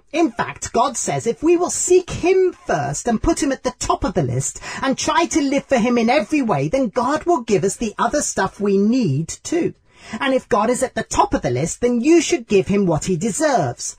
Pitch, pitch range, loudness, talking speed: 255 Hz, 200-315 Hz, -19 LUFS, 245 wpm